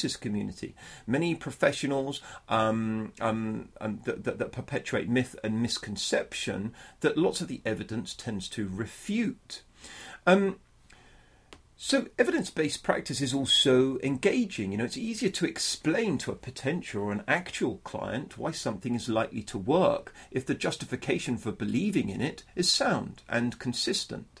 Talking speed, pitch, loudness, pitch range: 145 wpm, 130 Hz, -30 LUFS, 110-160 Hz